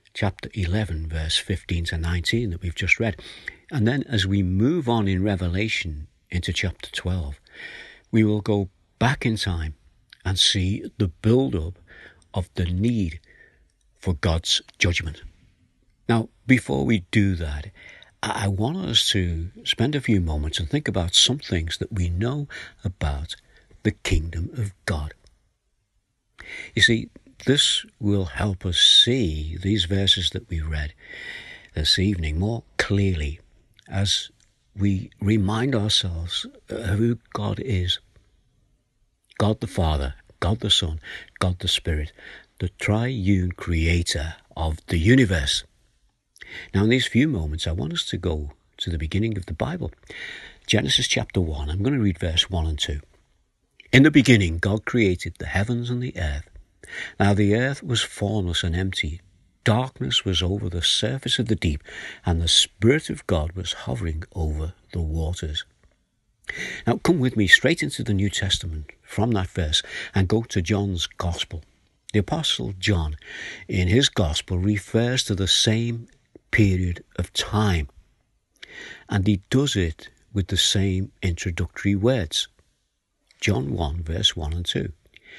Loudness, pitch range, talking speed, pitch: -23 LUFS, 85-110 Hz, 150 wpm, 95 Hz